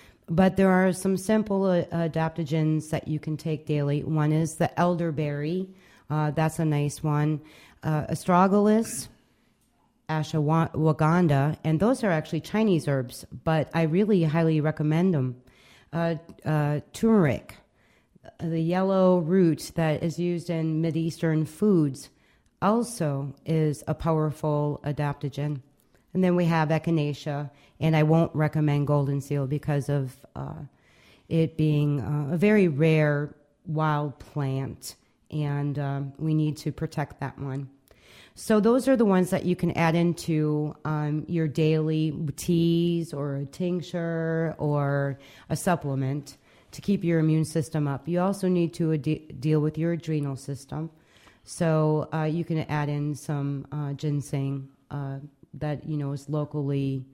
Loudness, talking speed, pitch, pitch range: -26 LUFS, 140 wpm, 155 Hz, 145-165 Hz